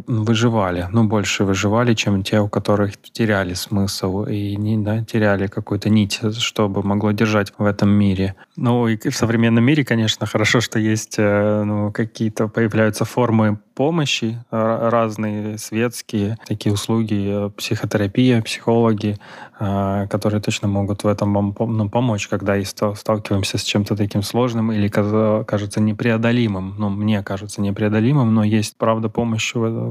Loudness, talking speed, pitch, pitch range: -19 LUFS, 140 wpm, 110 Hz, 105-115 Hz